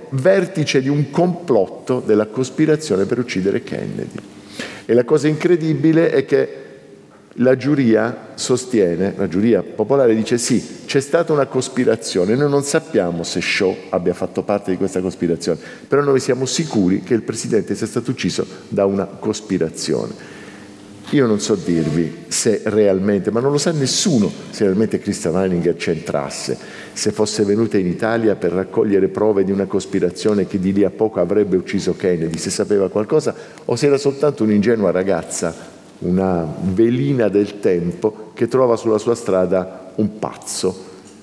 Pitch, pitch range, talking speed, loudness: 105 Hz, 95-130 Hz, 155 wpm, -18 LUFS